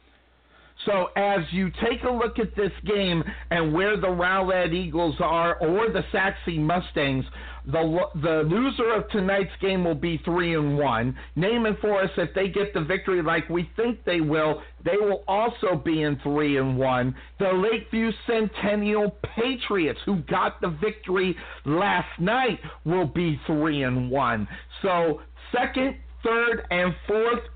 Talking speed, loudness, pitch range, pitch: 155 wpm, -25 LUFS, 160-210 Hz, 185 Hz